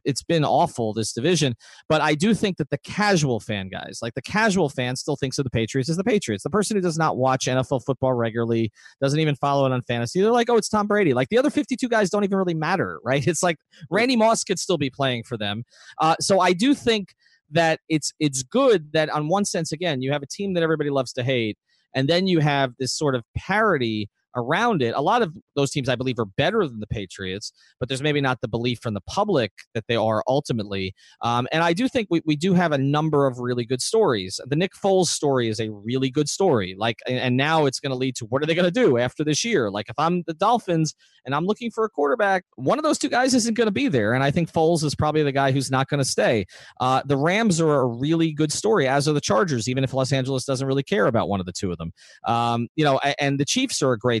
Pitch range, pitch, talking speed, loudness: 125-175 Hz, 145 Hz, 260 wpm, -22 LUFS